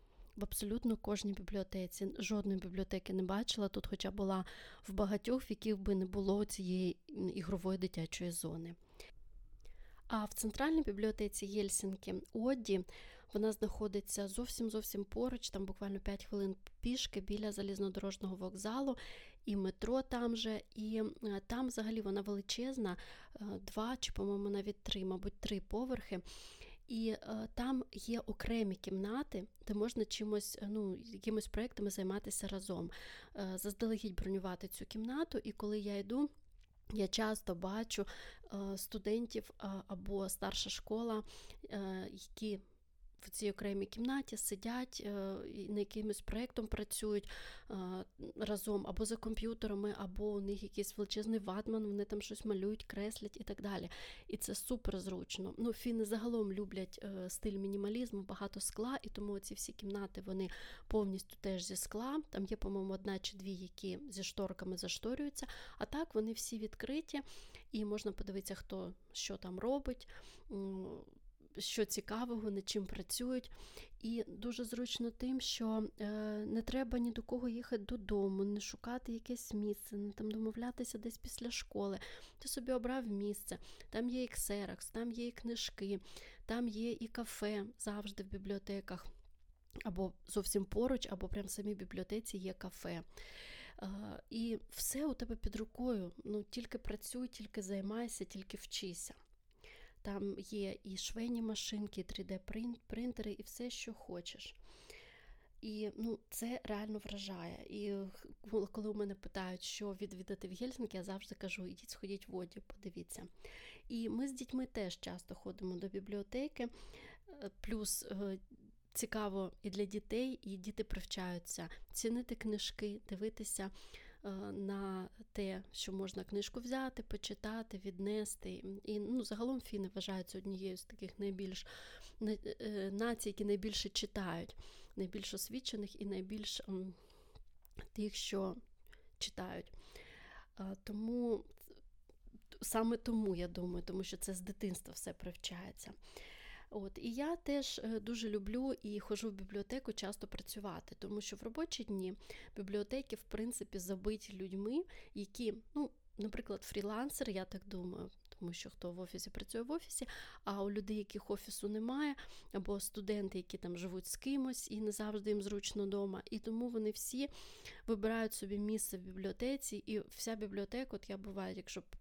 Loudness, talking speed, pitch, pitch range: -43 LUFS, 140 wpm, 210 Hz, 195-225 Hz